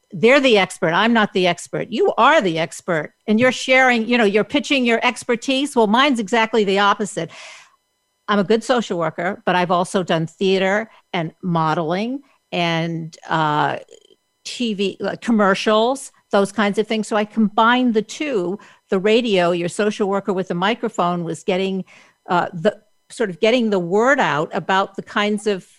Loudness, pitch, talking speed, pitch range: -18 LUFS, 205 Hz, 170 wpm, 180-230 Hz